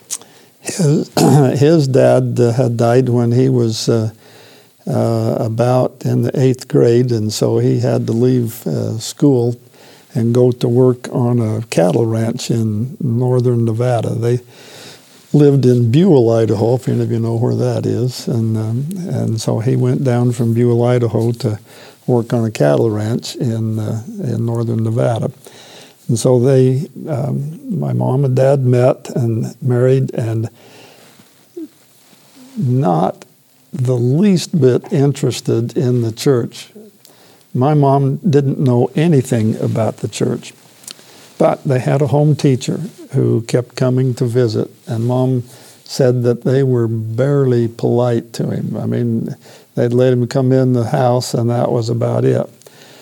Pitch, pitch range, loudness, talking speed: 125 Hz, 115-135 Hz, -15 LUFS, 140 wpm